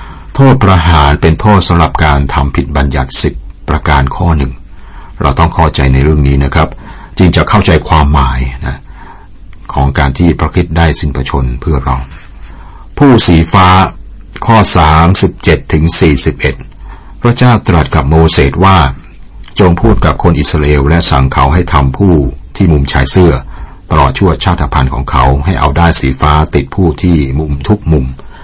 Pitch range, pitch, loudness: 70-90 Hz, 80 Hz, -8 LUFS